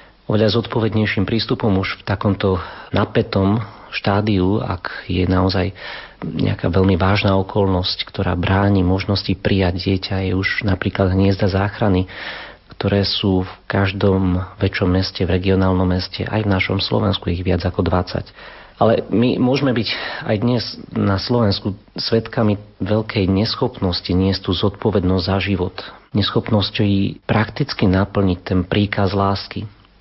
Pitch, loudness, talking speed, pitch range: 100 Hz, -19 LUFS, 130 wpm, 95-105 Hz